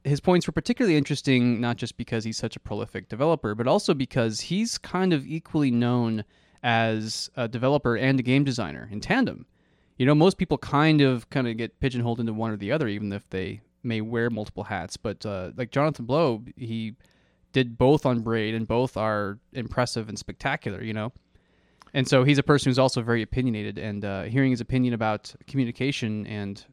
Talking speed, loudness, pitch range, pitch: 195 wpm, -25 LUFS, 110-135 Hz, 120 Hz